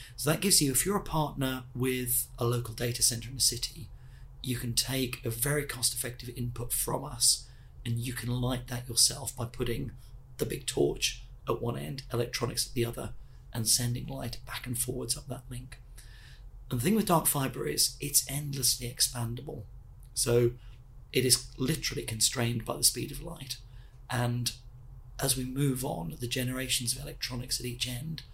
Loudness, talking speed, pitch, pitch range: -30 LUFS, 180 wpm, 125 Hz, 120-130 Hz